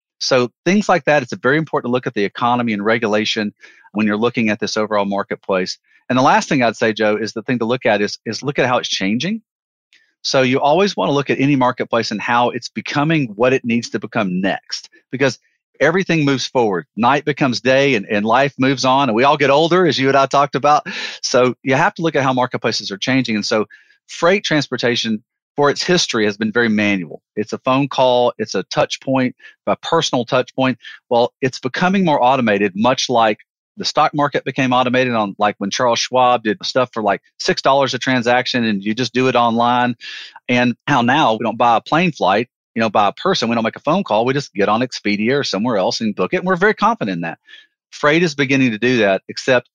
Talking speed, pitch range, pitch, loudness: 230 wpm, 110-145 Hz, 125 Hz, -17 LUFS